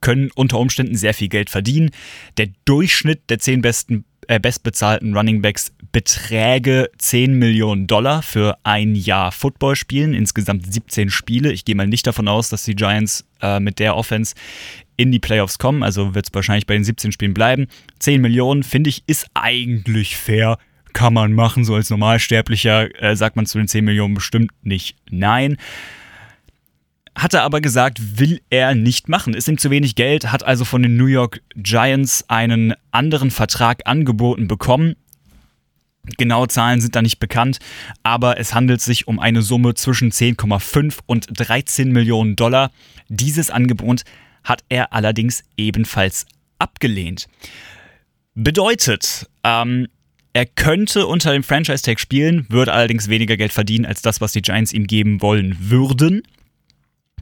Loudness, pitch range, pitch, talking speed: -16 LUFS, 105-130 Hz, 115 Hz, 155 wpm